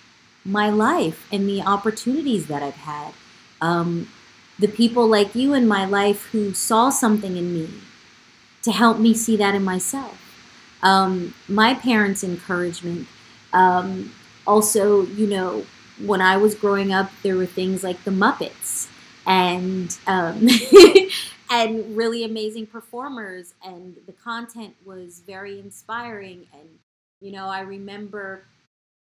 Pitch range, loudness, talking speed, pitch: 185-225 Hz, -19 LUFS, 130 wpm, 200 Hz